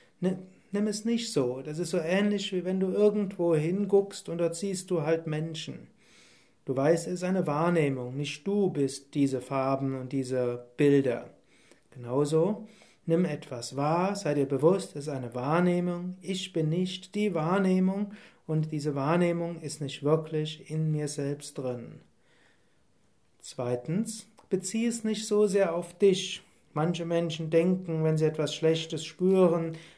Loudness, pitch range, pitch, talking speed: -29 LUFS, 145-185 Hz, 165 Hz, 150 wpm